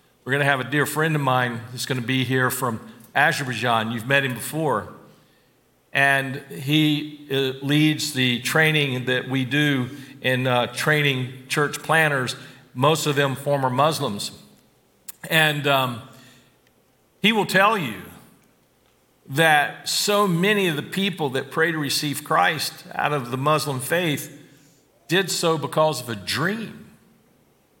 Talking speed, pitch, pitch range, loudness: 145 wpm, 140 Hz, 130-155 Hz, -21 LUFS